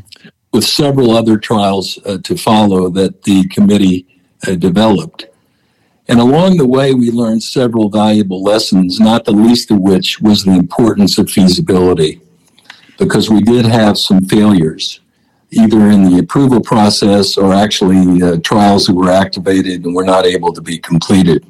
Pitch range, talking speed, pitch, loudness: 95-115 Hz, 155 wpm, 105 Hz, -10 LUFS